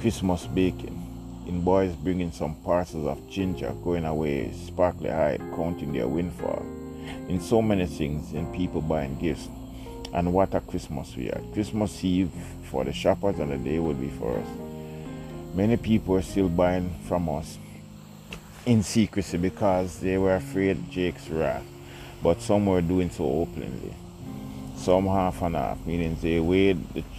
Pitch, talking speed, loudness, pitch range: 85 Hz, 160 wpm, -27 LUFS, 80-95 Hz